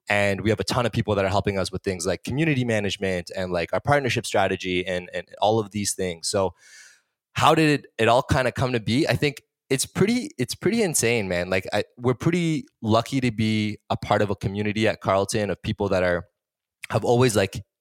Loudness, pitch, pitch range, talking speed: -23 LUFS, 110 Hz, 95-125 Hz, 225 wpm